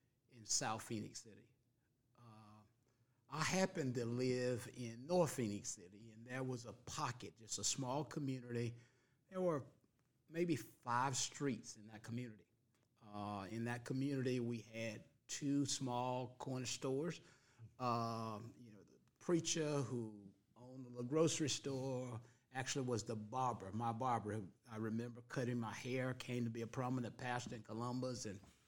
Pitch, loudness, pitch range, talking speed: 125 Hz, -43 LUFS, 115-130 Hz, 145 wpm